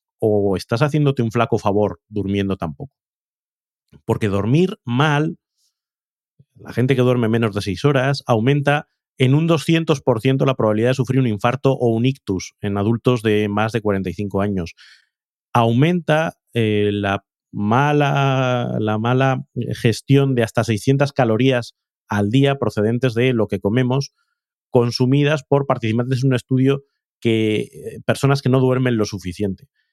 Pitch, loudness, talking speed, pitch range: 120 Hz, -19 LUFS, 140 wpm, 105-135 Hz